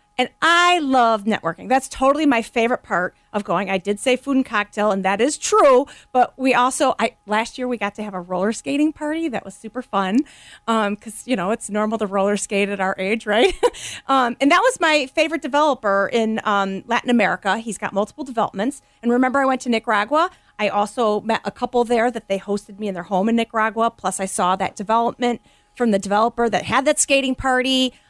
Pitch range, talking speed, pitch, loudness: 205-260 Hz, 215 wpm, 230 Hz, -20 LUFS